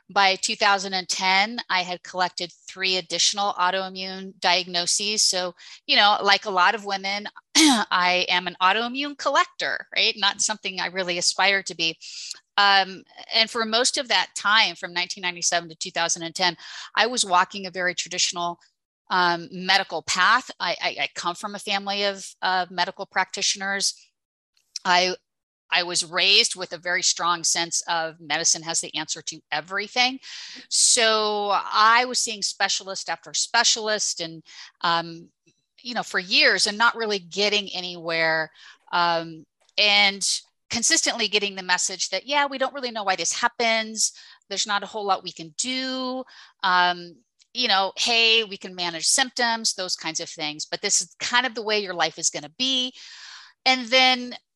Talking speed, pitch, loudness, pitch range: 160 wpm, 190 Hz, -22 LUFS, 175-220 Hz